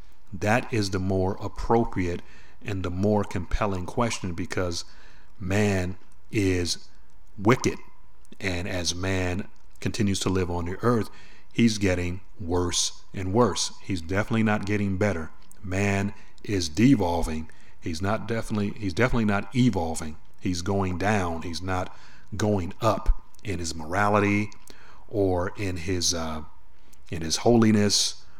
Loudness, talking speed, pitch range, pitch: -26 LUFS, 125 wpm, 90-105 Hz, 95 Hz